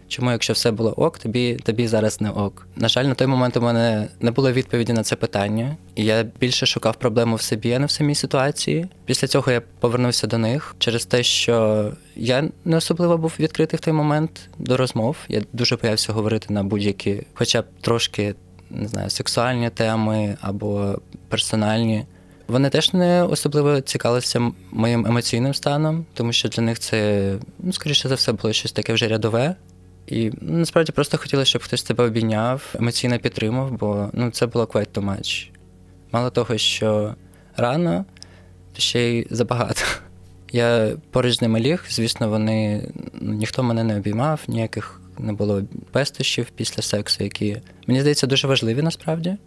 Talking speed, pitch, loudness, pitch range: 170 wpm, 115 Hz, -21 LUFS, 105-130 Hz